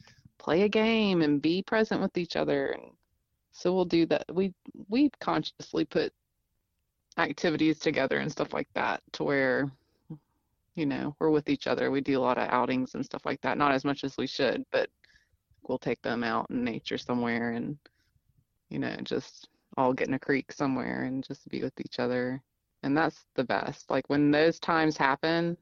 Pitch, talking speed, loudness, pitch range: 145 Hz, 190 wpm, -29 LUFS, 130-170 Hz